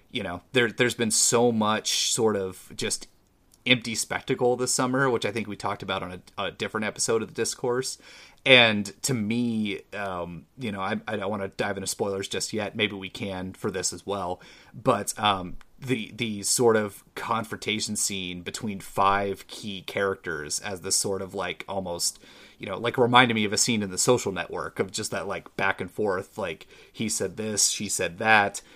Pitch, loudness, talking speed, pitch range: 105 Hz, -26 LUFS, 200 wpm, 95-120 Hz